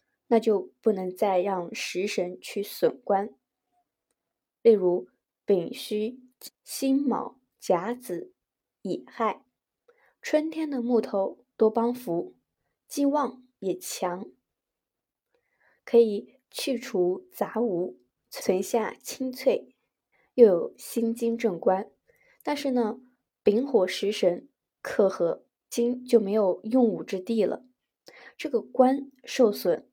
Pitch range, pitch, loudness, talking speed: 195-260 Hz, 230 Hz, -27 LUFS, 145 characters per minute